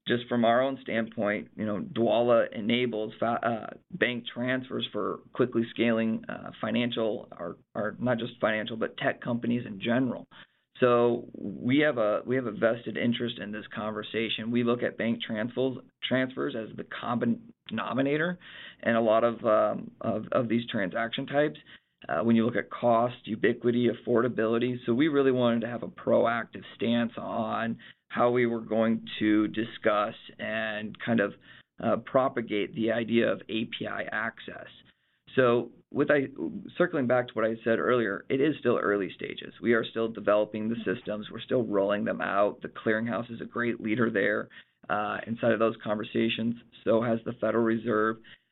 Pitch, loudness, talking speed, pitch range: 115 Hz, -28 LUFS, 170 wpm, 110-120 Hz